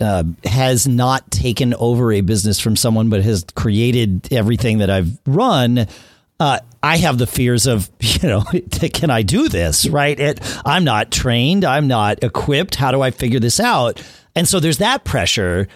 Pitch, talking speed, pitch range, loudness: 120 Hz, 180 wpm, 105-135 Hz, -16 LUFS